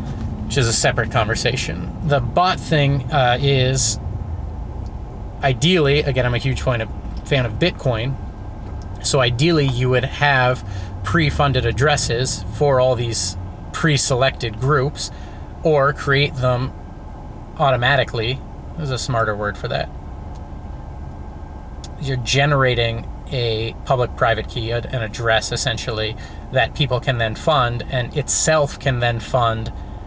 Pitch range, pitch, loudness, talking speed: 100-135 Hz, 120 Hz, -19 LUFS, 115 wpm